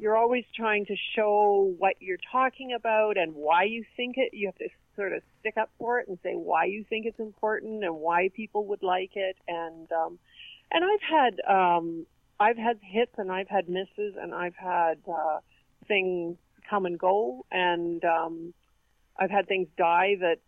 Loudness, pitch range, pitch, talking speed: -28 LUFS, 175-220 Hz, 195 Hz, 190 wpm